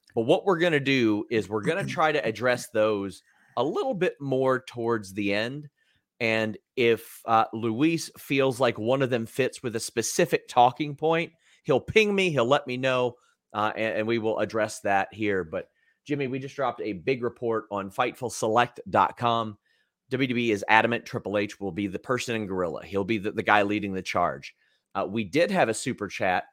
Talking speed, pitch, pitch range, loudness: 195 wpm, 115 Hz, 105-135 Hz, -26 LUFS